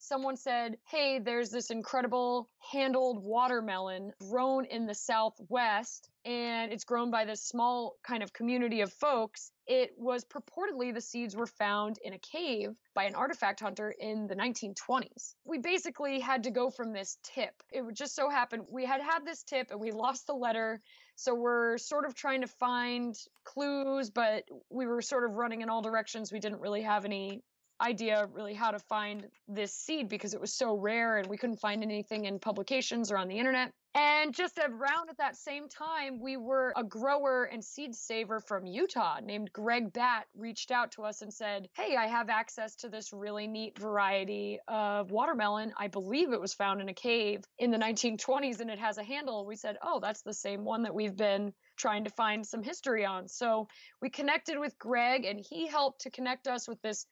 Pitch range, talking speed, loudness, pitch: 210-260 Hz, 200 wpm, -34 LUFS, 235 Hz